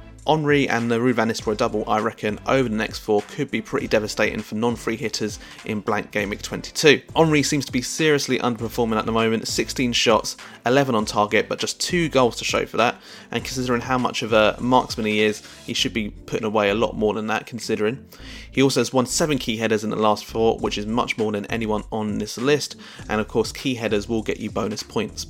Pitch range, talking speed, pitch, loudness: 110-130 Hz, 230 wpm, 115 Hz, -22 LUFS